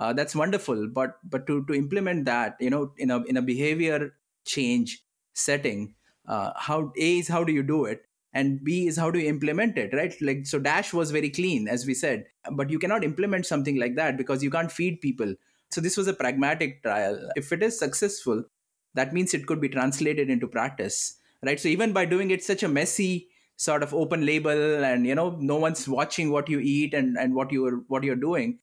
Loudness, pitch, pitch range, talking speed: -26 LUFS, 150 Hz, 135-175 Hz, 220 wpm